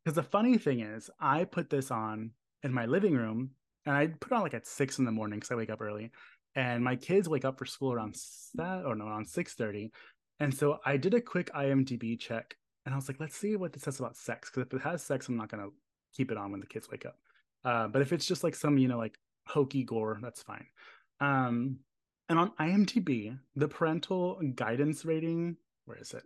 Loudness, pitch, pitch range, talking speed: -33 LUFS, 135 Hz, 115-160 Hz, 240 wpm